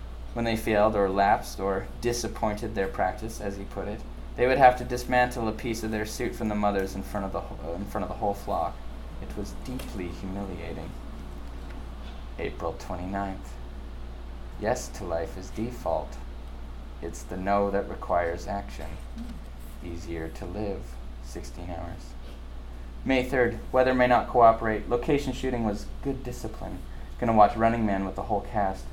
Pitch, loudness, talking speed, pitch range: 95 Hz, -28 LUFS, 160 wpm, 70-110 Hz